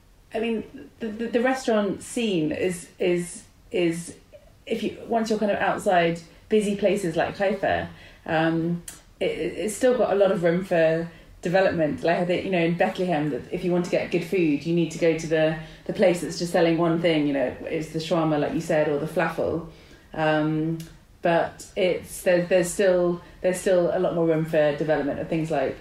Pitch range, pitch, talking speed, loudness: 160-190 Hz, 170 Hz, 200 wpm, -24 LUFS